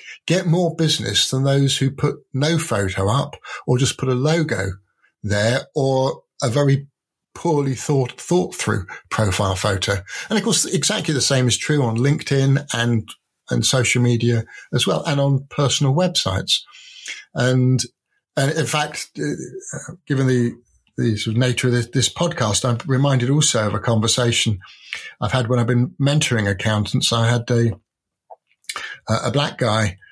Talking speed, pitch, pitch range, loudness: 155 wpm, 130 Hz, 115-145 Hz, -19 LUFS